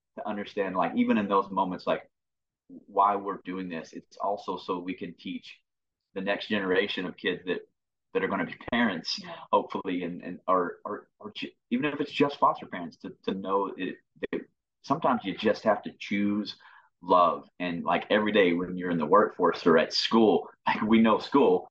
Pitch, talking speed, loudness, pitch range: 100 Hz, 190 wpm, -28 LUFS, 95-150 Hz